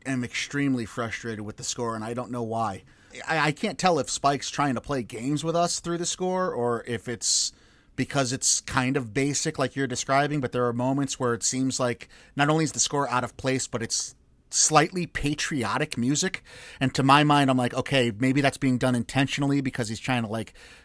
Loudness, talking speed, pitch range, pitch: -25 LUFS, 215 wpm, 120-140 Hz, 130 Hz